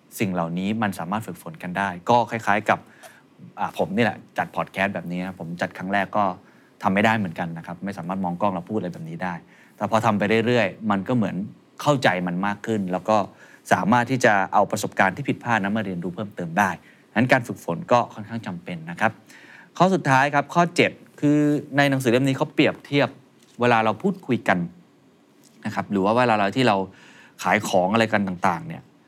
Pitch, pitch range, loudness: 105 Hz, 90-120 Hz, -23 LUFS